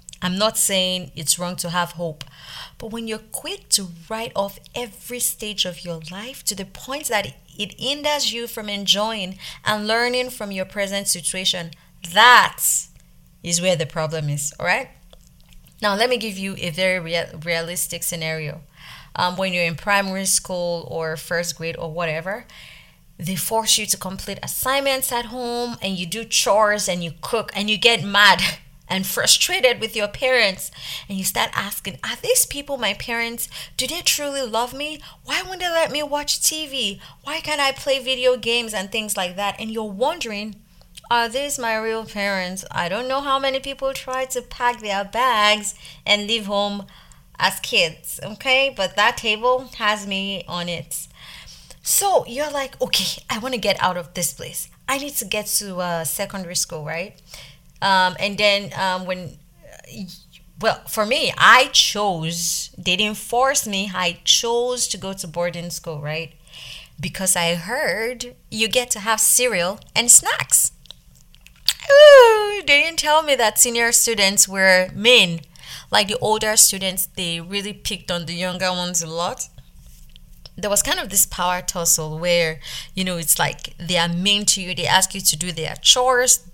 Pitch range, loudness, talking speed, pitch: 175-235 Hz, -19 LUFS, 175 wpm, 200 Hz